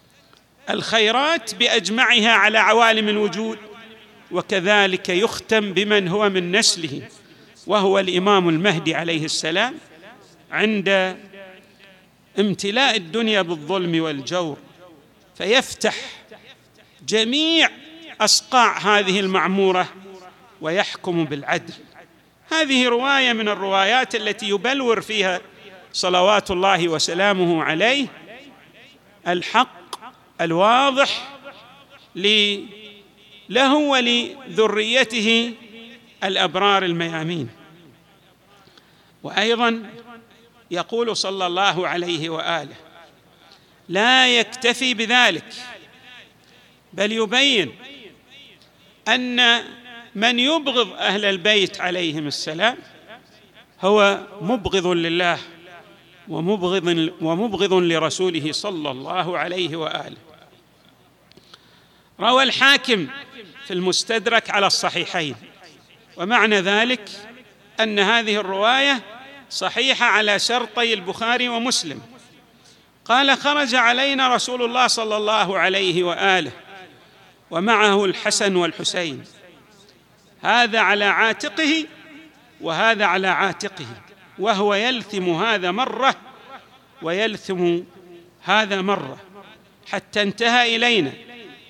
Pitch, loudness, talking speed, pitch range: 205 Hz, -19 LUFS, 75 wpm, 185-235 Hz